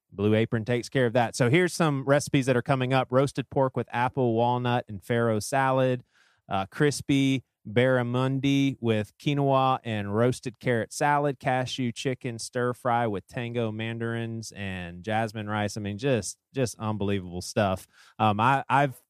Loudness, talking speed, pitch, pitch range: -27 LUFS, 155 wpm, 120 Hz, 110-135 Hz